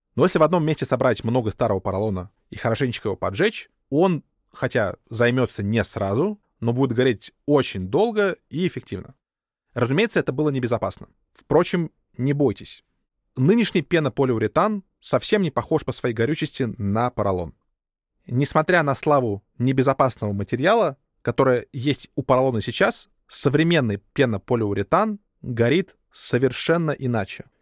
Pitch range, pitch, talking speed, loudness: 115-155 Hz, 130 Hz, 125 wpm, -22 LUFS